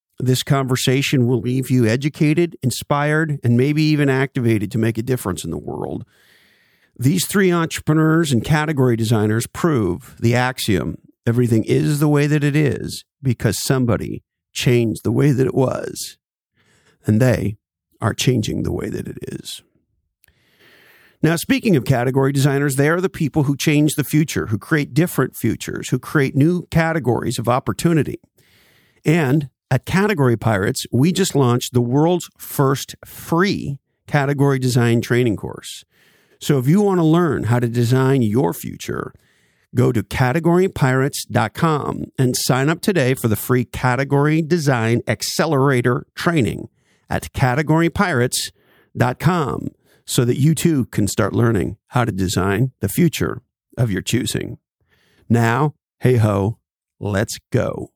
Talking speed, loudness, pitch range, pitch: 140 wpm, -18 LUFS, 120-150 Hz, 130 Hz